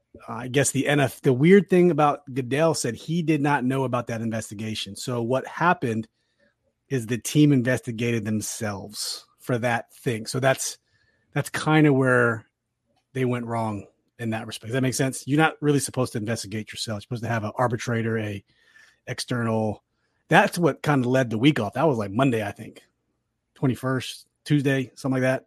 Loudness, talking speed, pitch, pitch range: -24 LUFS, 185 wpm, 125 Hz, 115-140 Hz